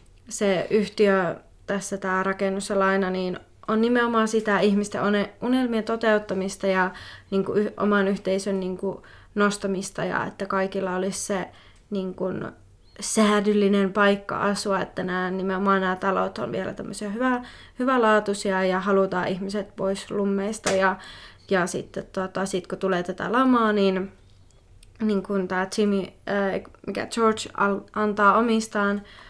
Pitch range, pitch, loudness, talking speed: 190-210 Hz, 195 Hz, -24 LUFS, 135 wpm